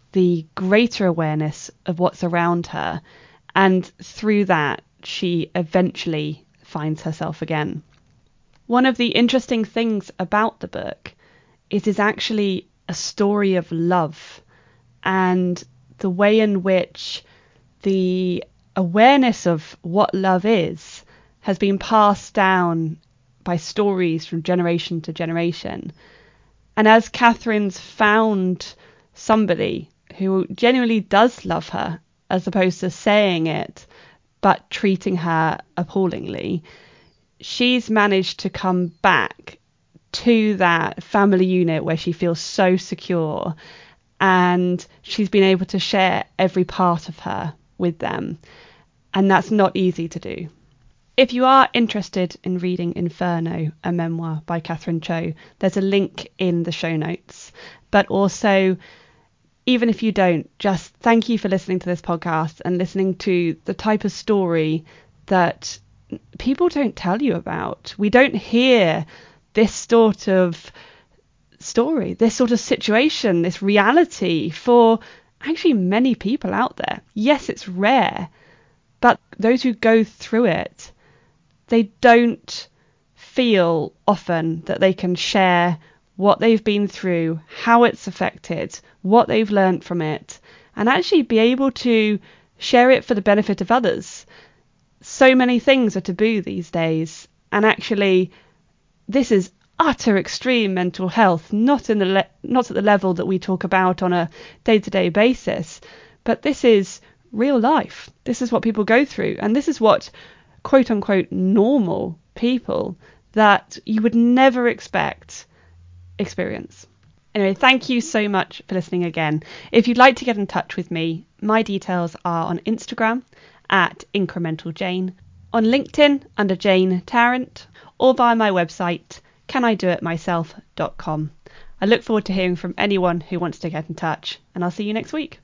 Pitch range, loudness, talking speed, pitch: 170-220 Hz, -19 LUFS, 140 wpm, 190 Hz